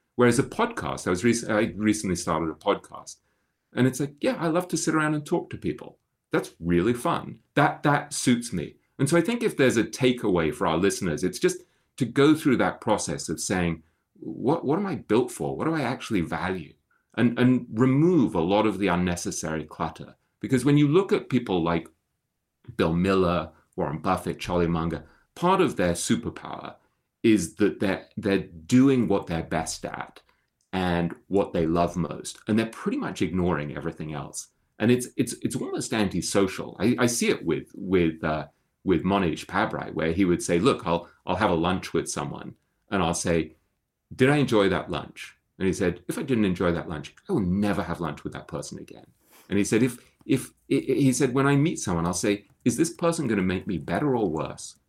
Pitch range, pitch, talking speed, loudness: 85-130 Hz, 100 Hz, 205 wpm, -25 LUFS